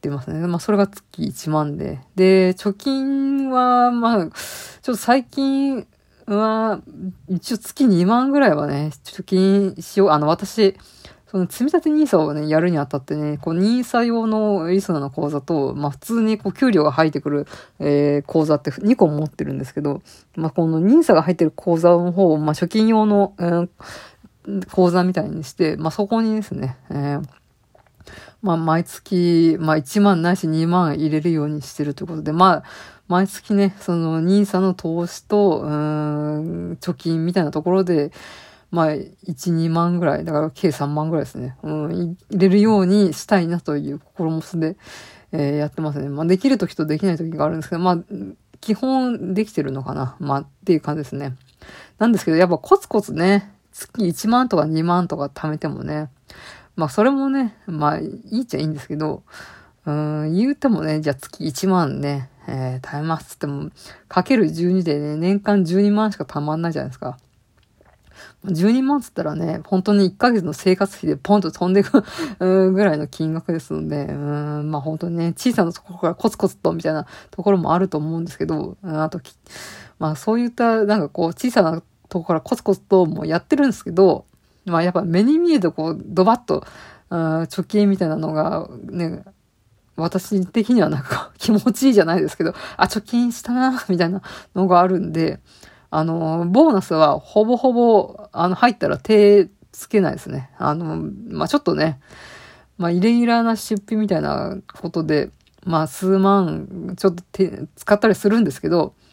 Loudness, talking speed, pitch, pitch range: -19 LUFS, 340 characters per minute, 175 Hz, 155-205 Hz